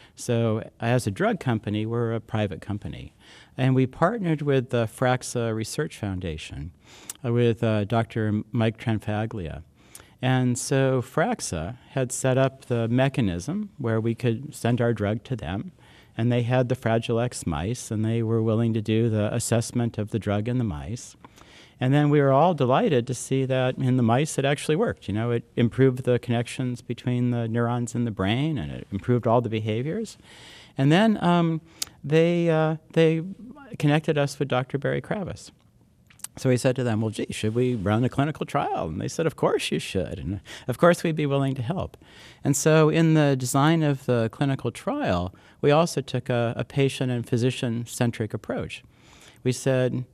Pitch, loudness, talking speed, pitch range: 125 Hz, -25 LUFS, 185 wpm, 115-140 Hz